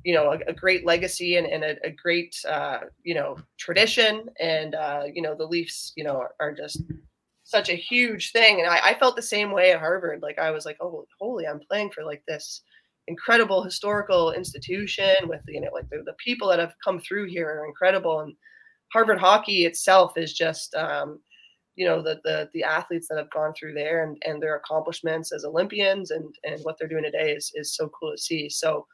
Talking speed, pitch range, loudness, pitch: 220 wpm, 155-205 Hz, -24 LUFS, 170 Hz